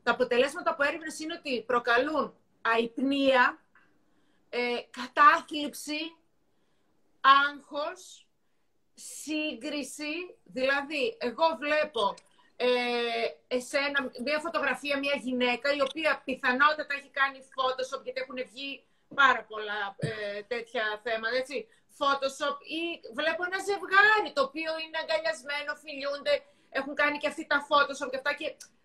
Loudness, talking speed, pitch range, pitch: -28 LUFS, 115 wpm, 255-300 Hz, 280 Hz